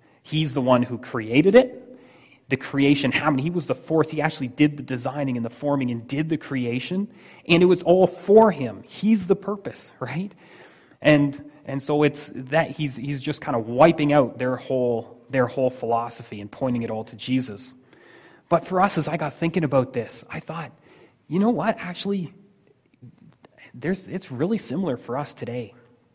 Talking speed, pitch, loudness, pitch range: 185 wpm, 145 Hz, -23 LUFS, 130-175 Hz